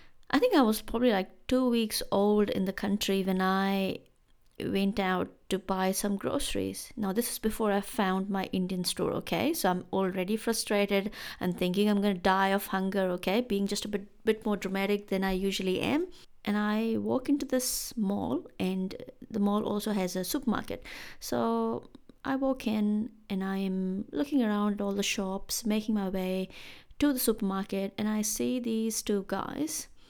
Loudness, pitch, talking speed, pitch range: -30 LUFS, 205 Hz, 180 wpm, 195-225 Hz